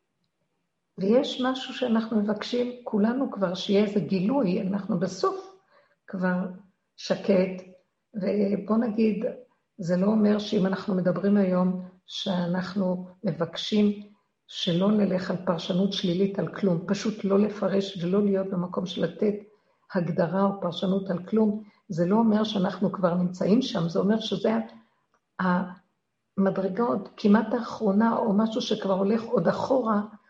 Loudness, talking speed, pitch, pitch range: -26 LUFS, 125 wpm, 195 Hz, 185-215 Hz